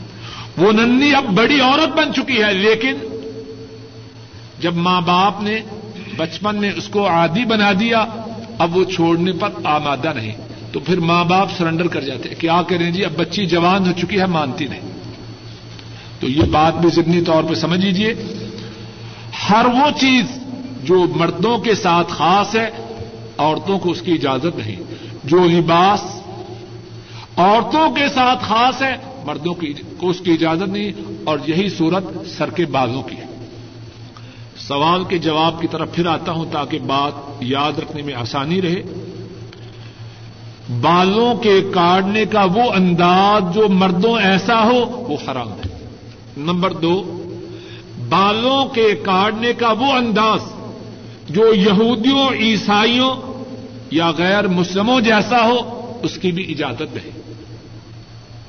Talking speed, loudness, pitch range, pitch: 145 wpm, -16 LUFS, 135-210 Hz, 175 Hz